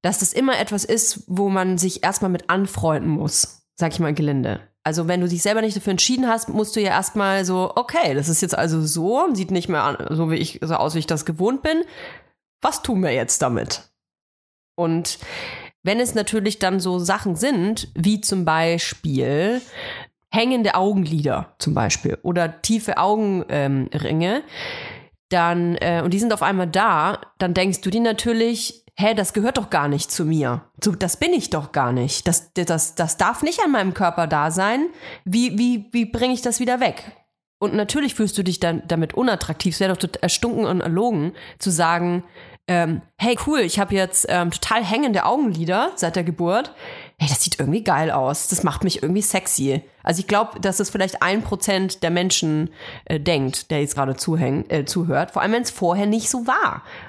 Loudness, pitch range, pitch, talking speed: -20 LUFS, 165-215 Hz, 185 Hz, 195 wpm